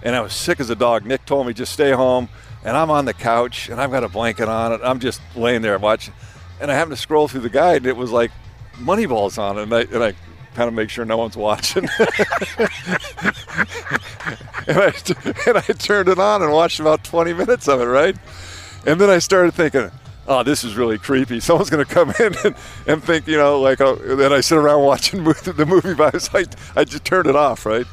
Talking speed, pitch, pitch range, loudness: 230 wpm, 130 Hz, 115-155 Hz, -17 LUFS